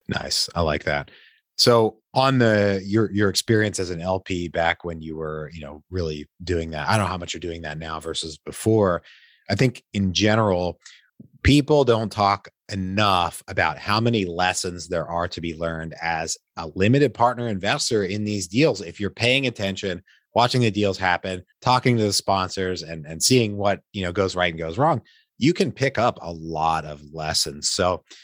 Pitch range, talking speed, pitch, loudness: 85-110 Hz, 190 wpm, 95 Hz, -22 LUFS